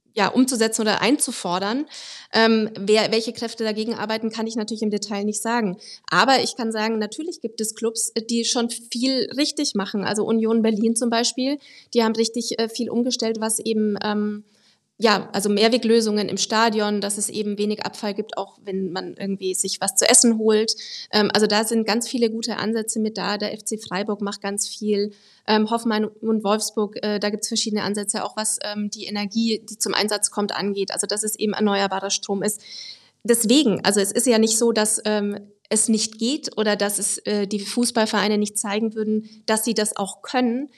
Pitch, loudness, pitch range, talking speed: 215 Hz, -22 LUFS, 205-230 Hz, 195 wpm